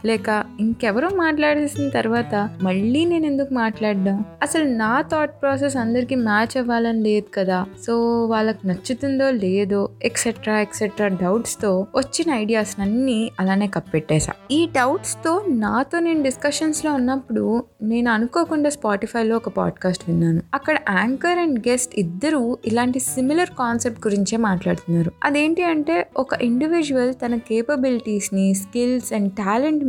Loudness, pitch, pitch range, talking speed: -21 LUFS, 235 Hz, 210-275 Hz, 130 wpm